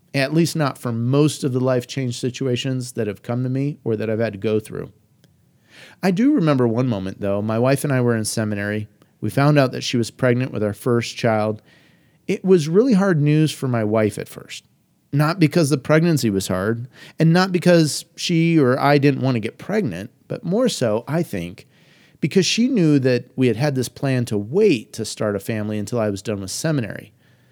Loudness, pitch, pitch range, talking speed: -20 LUFS, 130 Hz, 110-155 Hz, 215 wpm